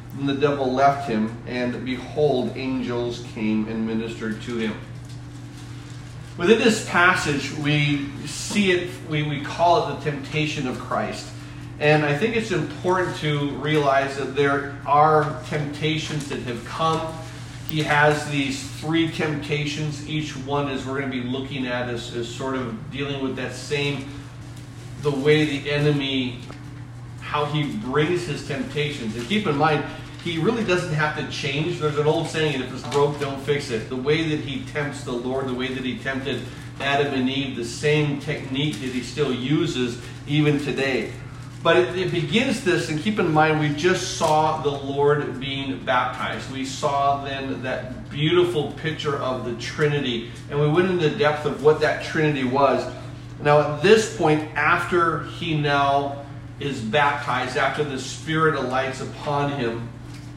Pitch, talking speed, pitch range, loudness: 140 Hz, 165 wpm, 125-150 Hz, -23 LUFS